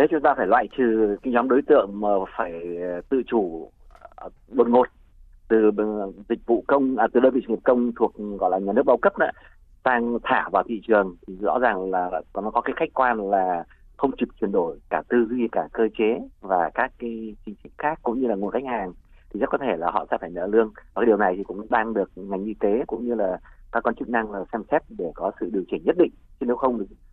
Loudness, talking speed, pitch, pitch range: -23 LUFS, 250 wpm, 115 Hz, 100-120 Hz